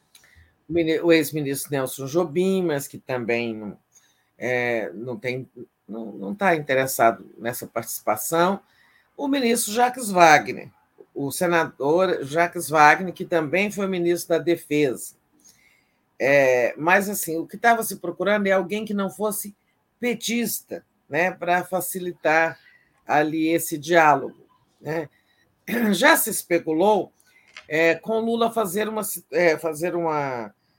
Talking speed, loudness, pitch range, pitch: 120 wpm, -22 LUFS, 150-195 Hz, 170 Hz